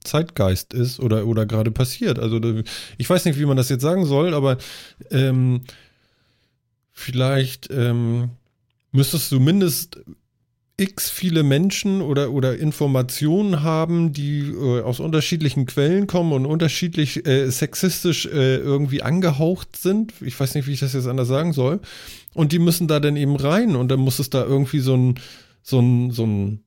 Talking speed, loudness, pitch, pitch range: 165 wpm, -20 LUFS, 135 Hz, 125-160 Hz